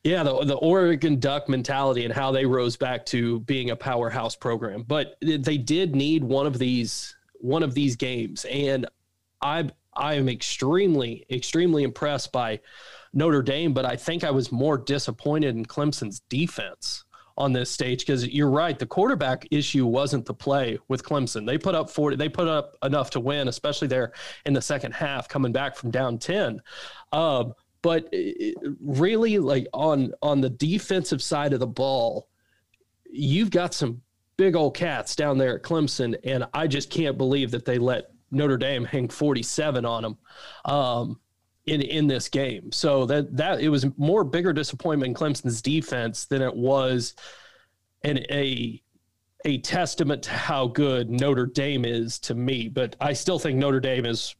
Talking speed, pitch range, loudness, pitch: 170 wpm, 125-150 Hz, -25 LUFS, 140 Hz